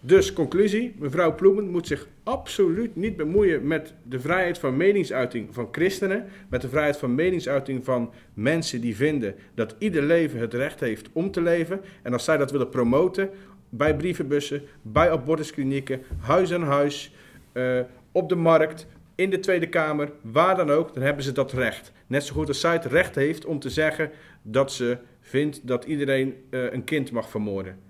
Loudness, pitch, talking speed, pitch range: -24 LUFS, 145 Hz, 180 wpm, 130-170 Hz